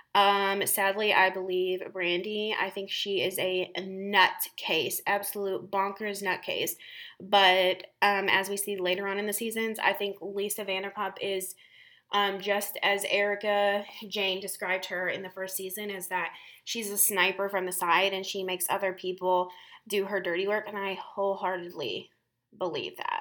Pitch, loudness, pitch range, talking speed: 195 Hz, -28 LUFS, 185-205 Hz, 160 wpm